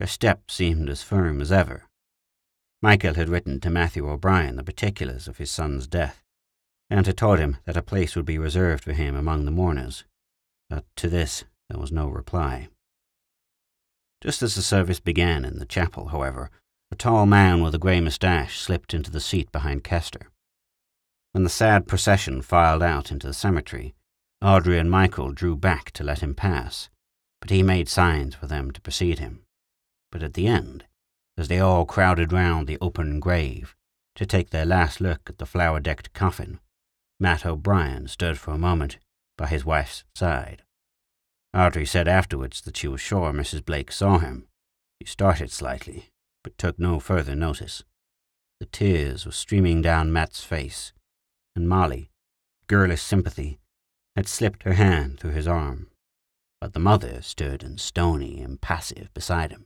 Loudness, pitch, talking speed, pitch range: -24 LUFS, 85 Hz, 170 wpm, 75-95 Hz